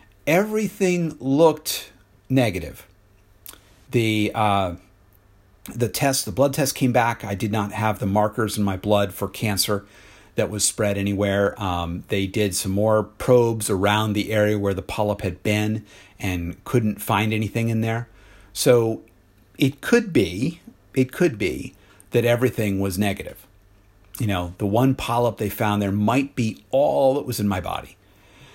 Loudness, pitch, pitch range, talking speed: -22 LUFS, 105 Hz, 100-120 Hz, 155 wpm